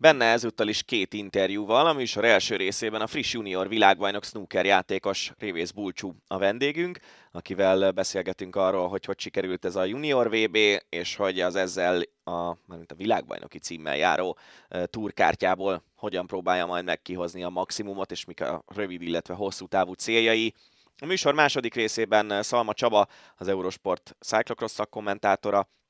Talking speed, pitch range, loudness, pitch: 150 wpm, 95-110 Hz, -26 LUFS, 100 Hz